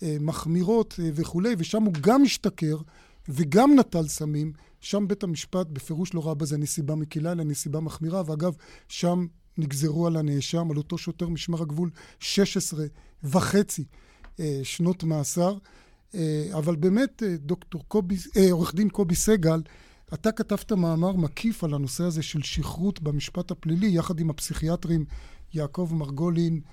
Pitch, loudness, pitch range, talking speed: 170 Hz, -26 LUFS, 155-185 Hz, 125 wpm